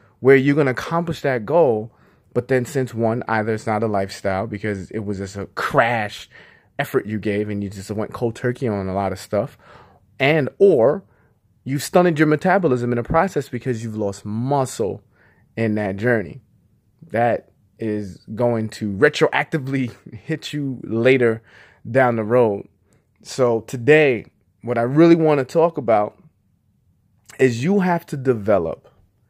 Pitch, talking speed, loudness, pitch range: 120 Hz, 160 wpm, -20 LUFS, 105-145 Hz